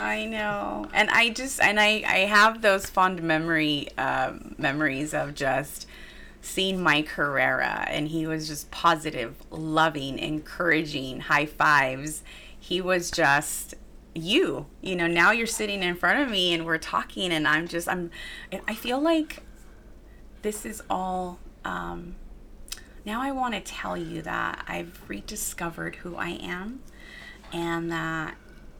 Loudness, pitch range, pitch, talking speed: -25 LUFS, 155-210 Hz, 170 Hz, 145 wpm